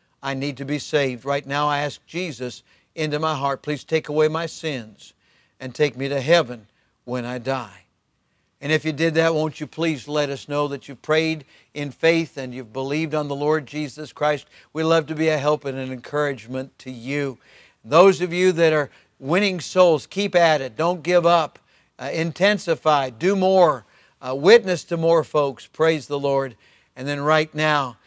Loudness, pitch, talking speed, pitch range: -21 LUFS, 150 Hz, 190 wpm, 135-160 Hz